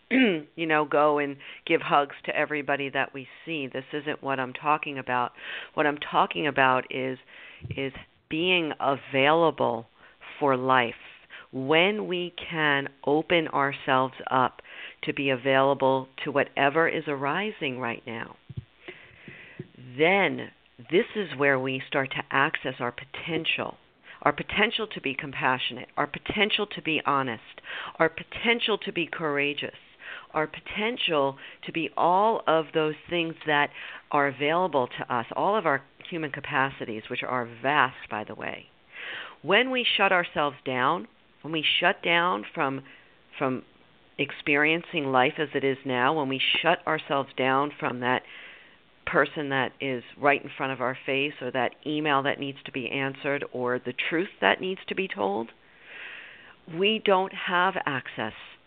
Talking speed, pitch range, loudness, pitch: 145 wpm, 135-160 Hz, -26 LUFS, 145 Hz